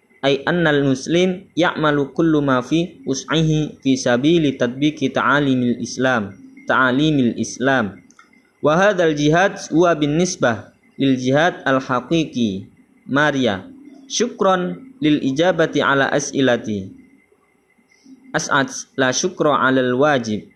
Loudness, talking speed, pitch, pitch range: -18 LUFS, 90 wpm, 150 Hz, 130-185 Hz